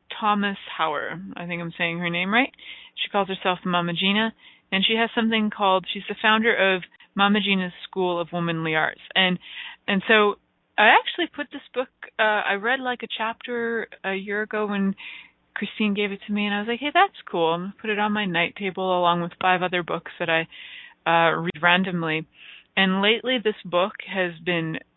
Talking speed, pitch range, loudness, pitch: 200 wpm, 180-225 Hz, -23 LUFS, 200 Hz